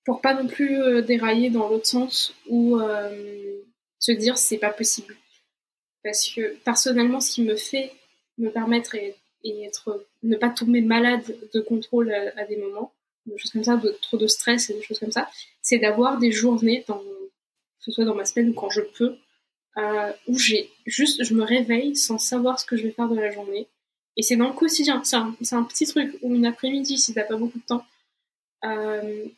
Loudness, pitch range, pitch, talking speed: -22 LUFS, 215-245 Hz, 235 Hz, 210 wpm